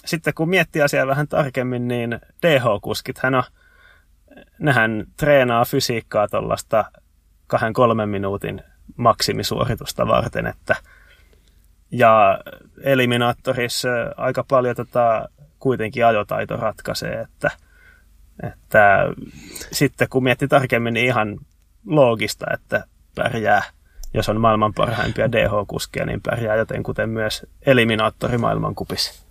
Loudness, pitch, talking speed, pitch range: -20 LUFS, 120 Hz, 110 wpm, 110-135 Hz